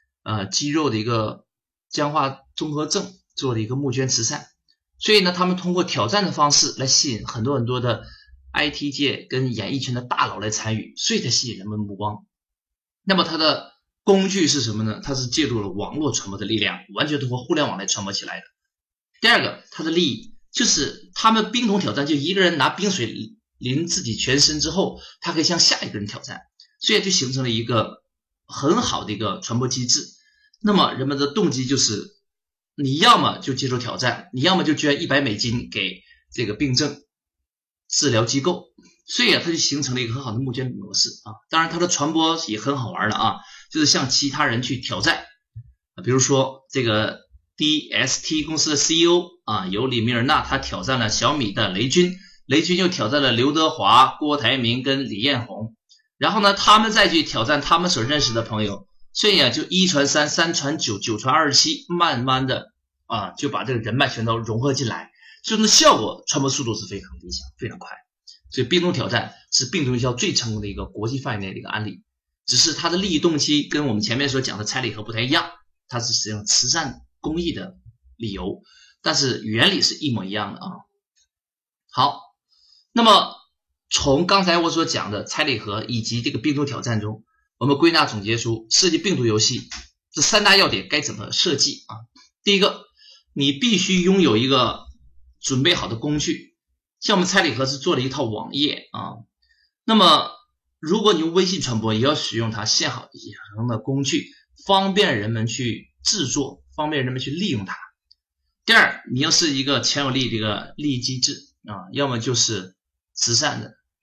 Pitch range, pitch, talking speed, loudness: 110-170 Hz, 135 Hz, 290 characters per minute, -20 LUFS